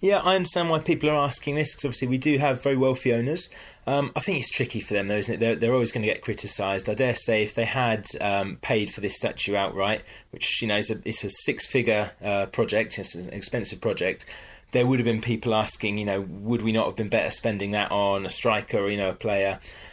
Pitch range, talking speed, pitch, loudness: 100-135 Hz, 245 wpm, 110 Hz, -25 LUFS